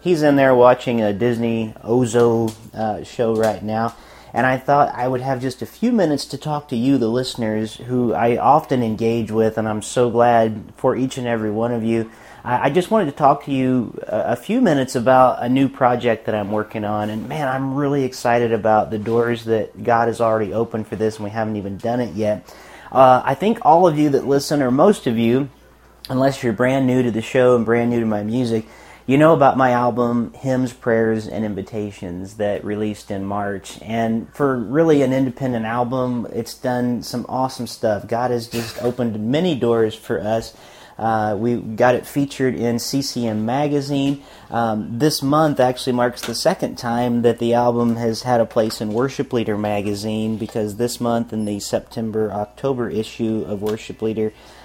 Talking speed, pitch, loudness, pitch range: 200 wpm, 120 Hz, -19 LUFS, 110-130 Hz